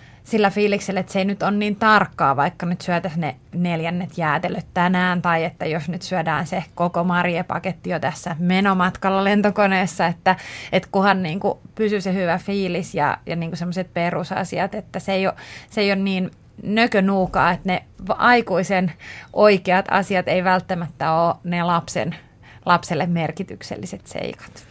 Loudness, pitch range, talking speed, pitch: -21 LUFS, 170-195 Hz, 155 wpm, 185 Hz